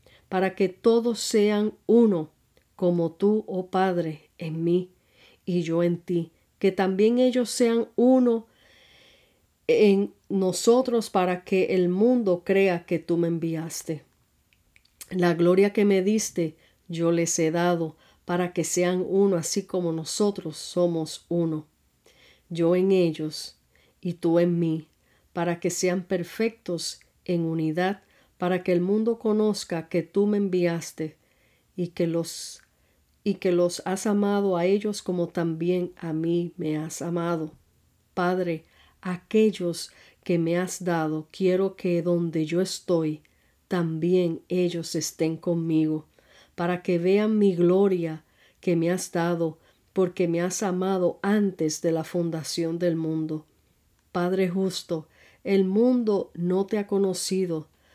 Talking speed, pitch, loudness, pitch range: 135 wpm, 175 Hz, -25 LUFS, 165-195 Hz